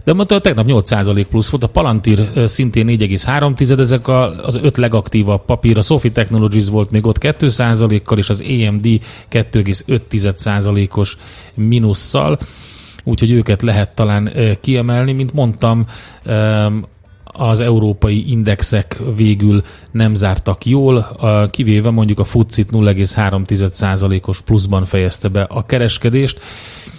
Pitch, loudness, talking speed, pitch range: 110 Hz, -13 LUFS, 115 wpm, 105-120 Hz